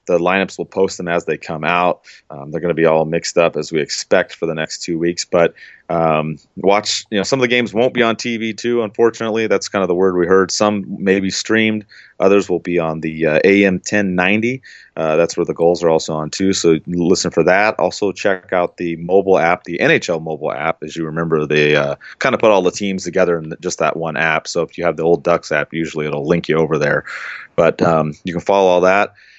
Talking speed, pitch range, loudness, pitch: 245 wpm, 80-100 Hz, -16 LUFS, 90 Hz